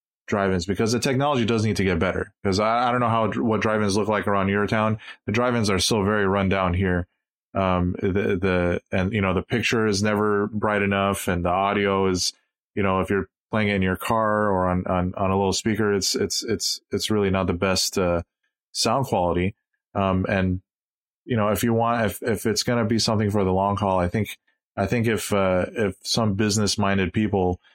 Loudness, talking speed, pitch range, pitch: -23 LUFS, 220 wpm, 95-110 Hz, 100 Hz